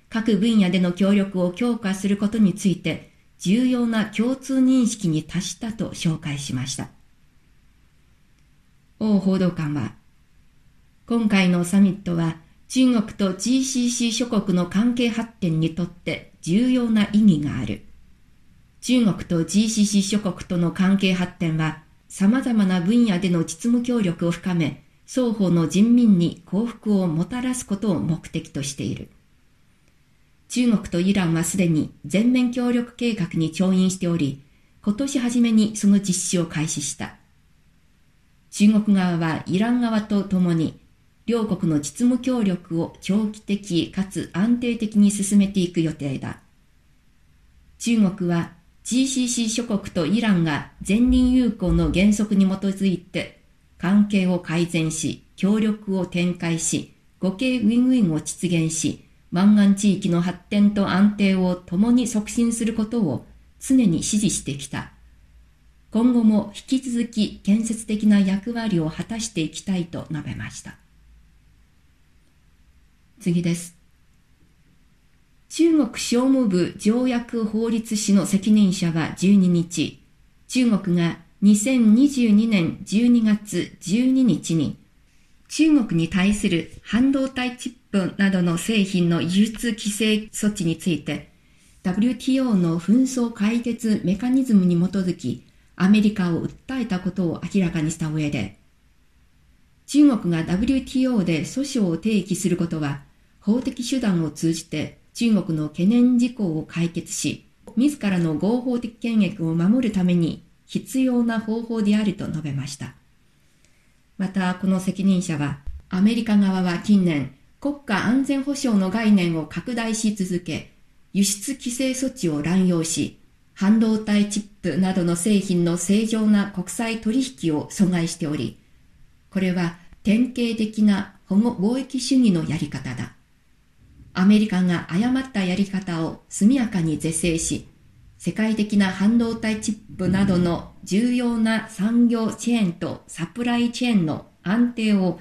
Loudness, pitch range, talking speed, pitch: -21 LUFS, 170-225 Hz, 250 characters per minute, 195 Hz